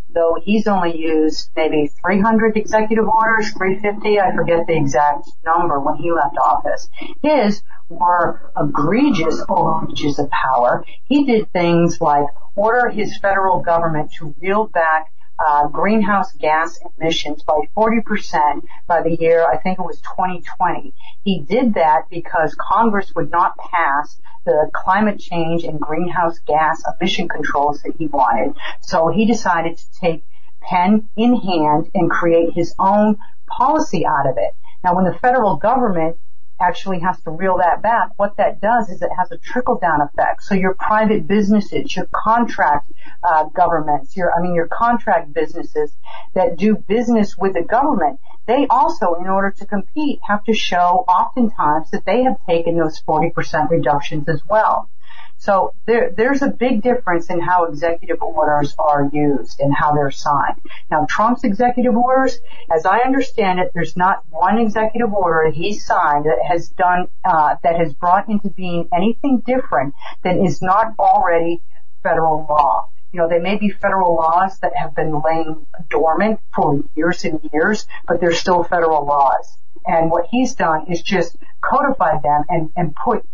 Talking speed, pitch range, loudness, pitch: 160 wpm, 160-215 Hz, -17 LUFS, 180 Hz